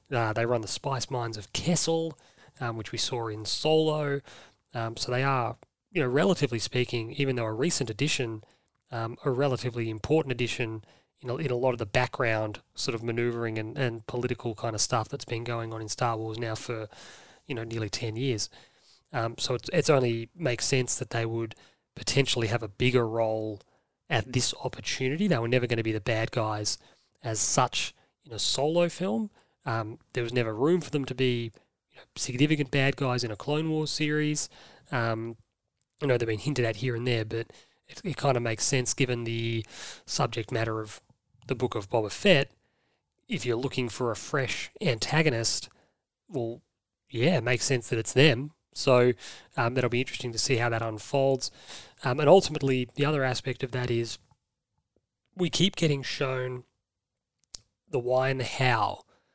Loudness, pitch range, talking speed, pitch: -28 LUFS, 115-135 Hz, 185 wpm, 125 Hz